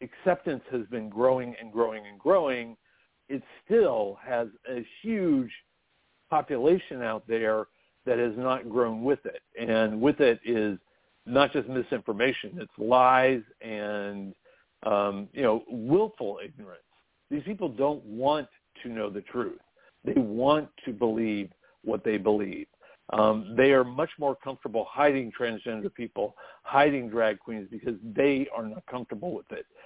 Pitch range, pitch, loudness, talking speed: 110-145 Hz, 125 Hz, -28 LUFS, 145 wpm